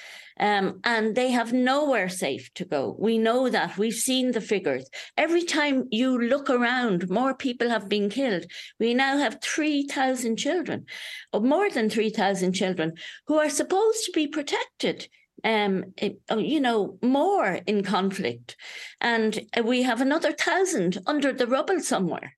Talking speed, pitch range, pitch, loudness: 150 wpm, 205-285 Hz, 240 Hz, -25 LUFS